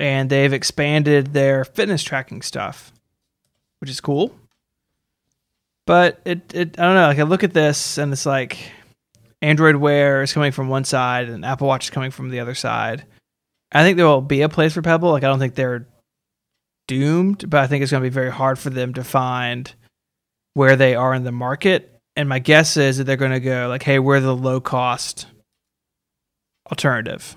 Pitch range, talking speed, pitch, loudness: 130-150 Hz, 195 wpm, 135 Hz, -18 LUFS